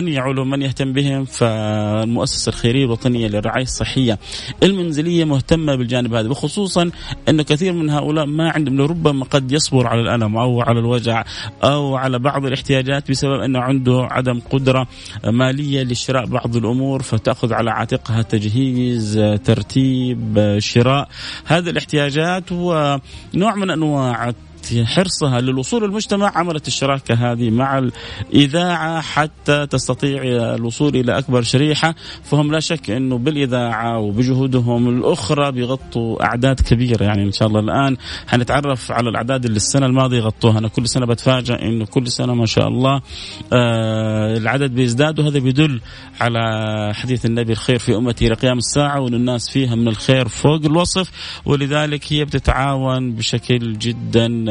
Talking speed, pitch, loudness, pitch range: 135 wpm, 130 Hz, -17 LUFS, 115-140 Hz